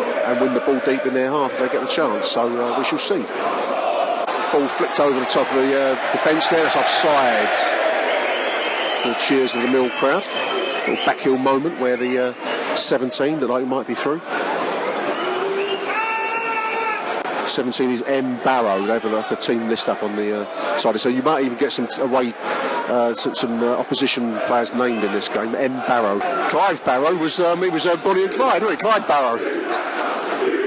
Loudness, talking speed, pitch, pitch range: -19 LUFS, 195 wpm, 130 Hz, 120-190 Hz